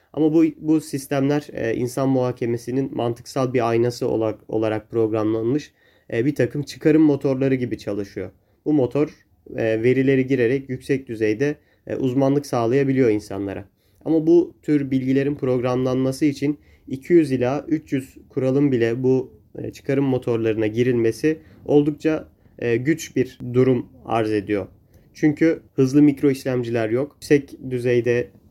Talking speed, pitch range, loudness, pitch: 115 wpm, 115-145 Hz, -21 LUFS, 130 Hz